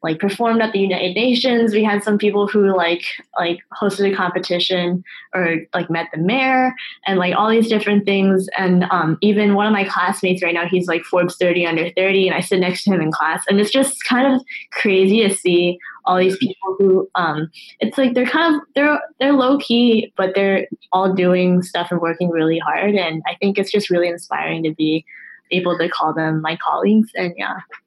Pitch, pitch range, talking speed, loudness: 190 Hz, 175-210 Hz, 210 wpm, -17 LUFS